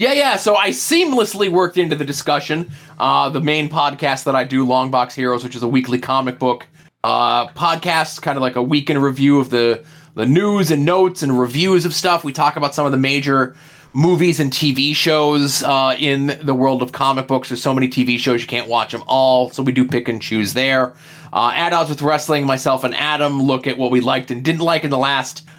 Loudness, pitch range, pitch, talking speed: -17 LUFS, 130-155 Hz, 140 Hz, 225 wpm